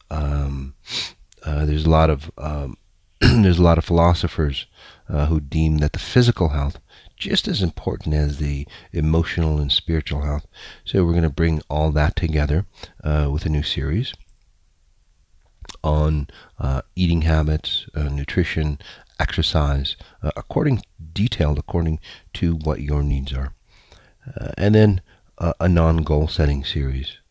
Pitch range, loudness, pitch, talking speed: 75-85 Hz, -21 LUFS, 80 Hz, 145 wpm